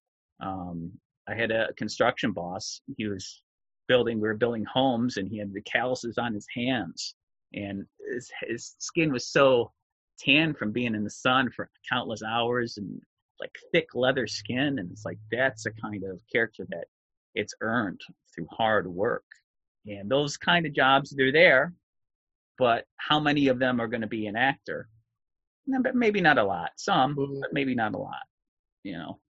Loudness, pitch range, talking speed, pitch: -27 LUFS, 105-135 Hz, 175 wpm, 120 Hz